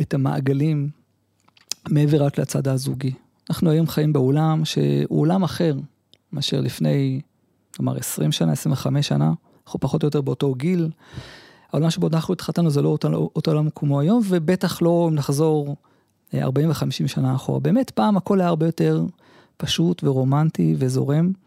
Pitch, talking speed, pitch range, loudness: 150 Hz, 155 wpm, 135-165 Hz, -21 LUFS